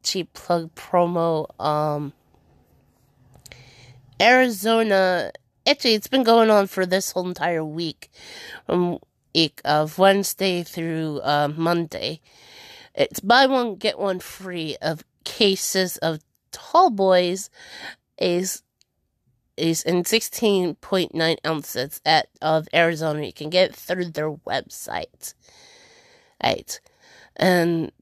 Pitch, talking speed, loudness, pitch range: 175 Hz, 110 wpm, -21 LUFS, 155-195 Hz